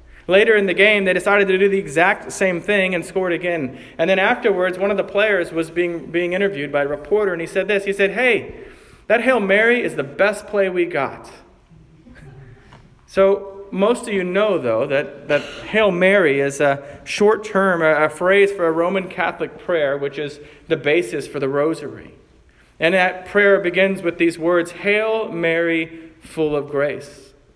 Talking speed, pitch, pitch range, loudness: 185 wpm, 180 Hz, 150-200 Hz, -18 LUFS